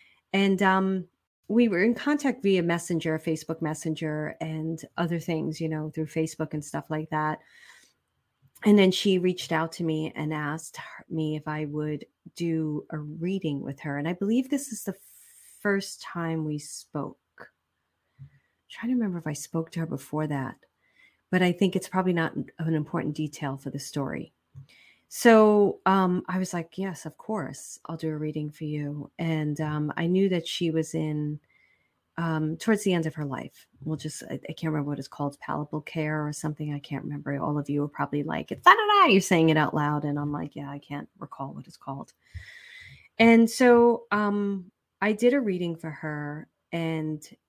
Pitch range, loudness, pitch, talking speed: 150-190 Hz, -27 LUFS, 160 Hz, 190 wpm